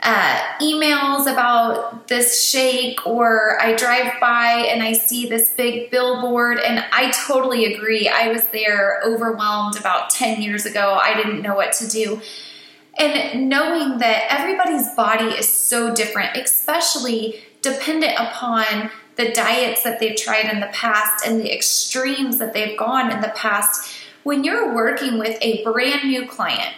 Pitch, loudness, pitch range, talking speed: 235 Hz, -17 LUFS, 220-255 Hz, 155 wpm